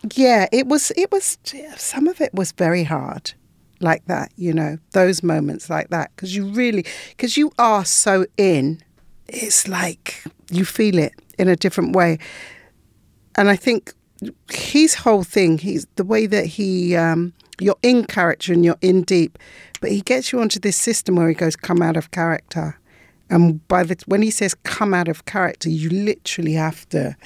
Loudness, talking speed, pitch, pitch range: -18 LUFS, 185 wpm, 185 Hz, 170-220 Hz